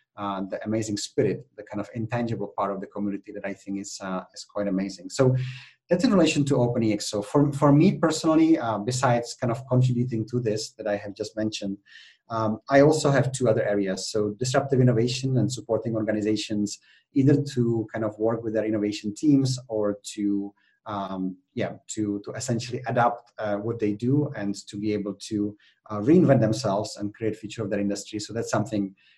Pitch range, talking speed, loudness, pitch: 105-125 Hz, 195 wpm, -25 LUFS, 110 Hz